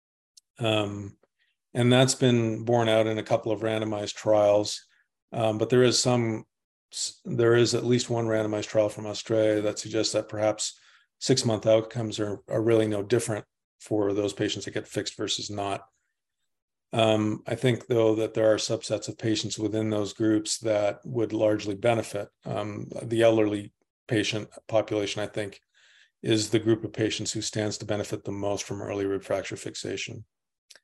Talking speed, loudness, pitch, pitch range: 165 wpm, -27 LUFS, 110 Hz, 105-115 Hz